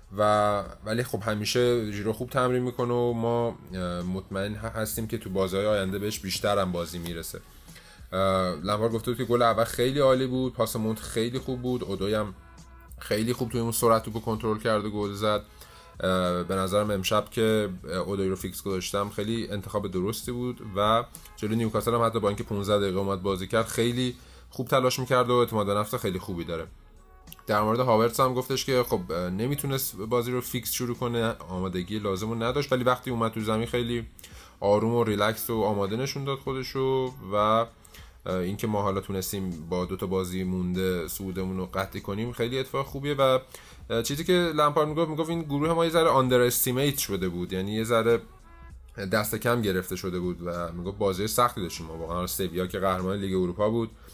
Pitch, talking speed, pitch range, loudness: 110 Hz, 180 wpm, 95-120 Hz, -27 LUFS